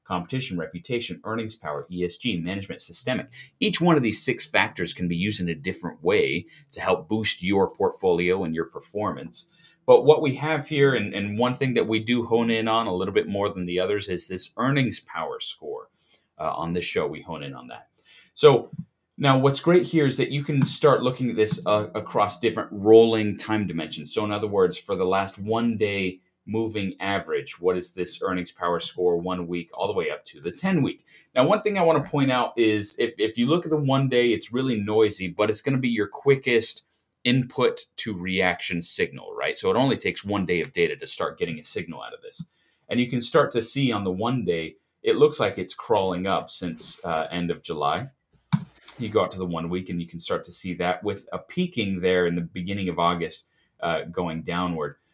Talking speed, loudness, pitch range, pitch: 225 wpm, -24 LUFS, 90-135 Hz, 110 Hz